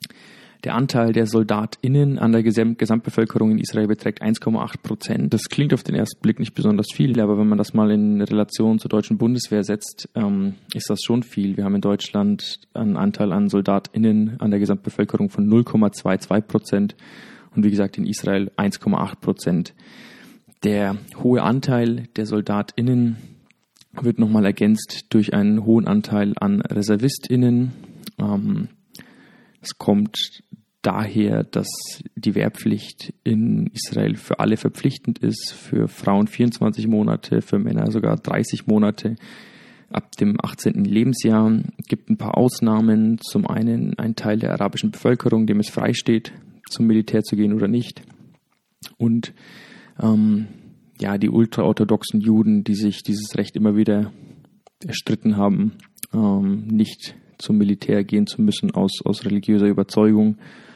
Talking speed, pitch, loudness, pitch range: 145 wpm, 110 Hz, -20 LUFS, 105-130 Hz